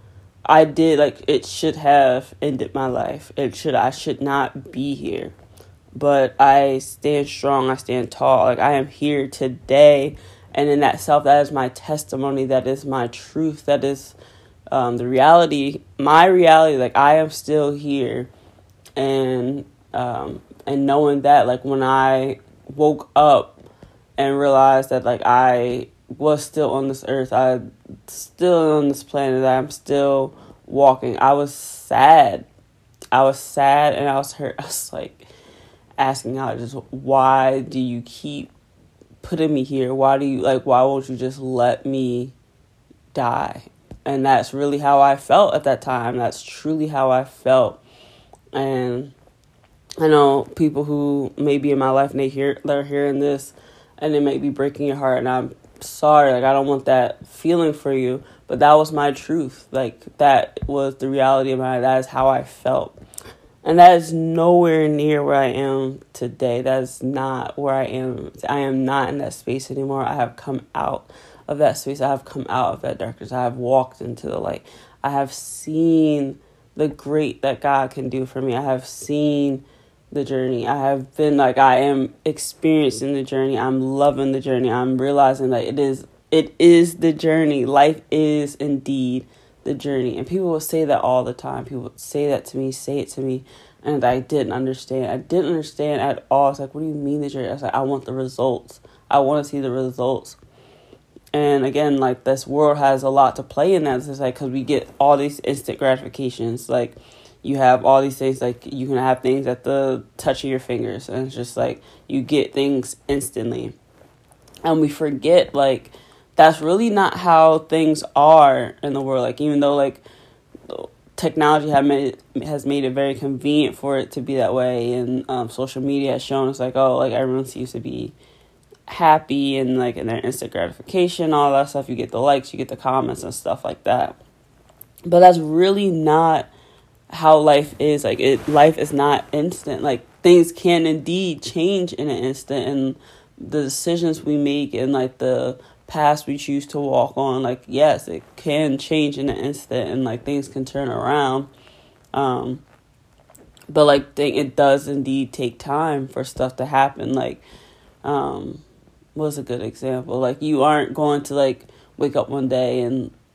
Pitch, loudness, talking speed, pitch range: 135 Hz, -19 LUFS, 185 wpm, 130-145 Hz